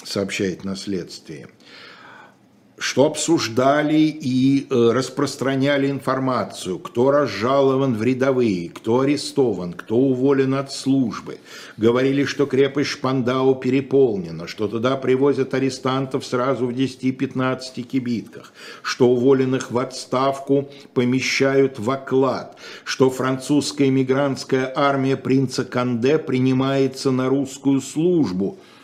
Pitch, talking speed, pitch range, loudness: 130 Hz, 100 wpm, 125-135 Hz, -20 LUFS